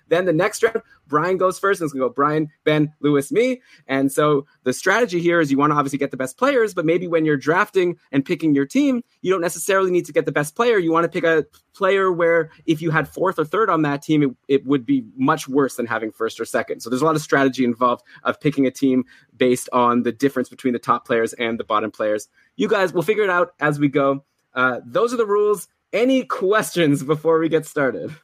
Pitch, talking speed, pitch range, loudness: 155 Hz, 250 wpm, 135-175 Hz, -20 LUFS